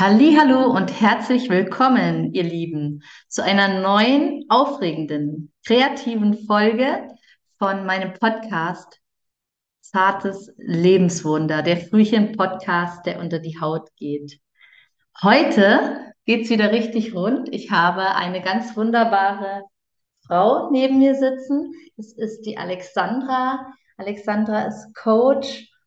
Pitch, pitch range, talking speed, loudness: 210 Hz, 180-245 Hz, 105 wpm, -19 LUFS